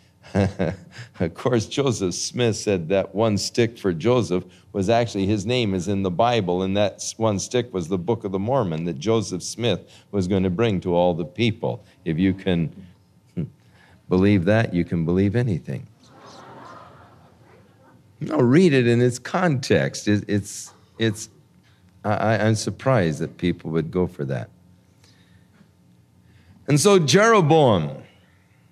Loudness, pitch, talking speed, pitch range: -22 LUFS, 100 Hz, 145 wpm, 90-115 Hz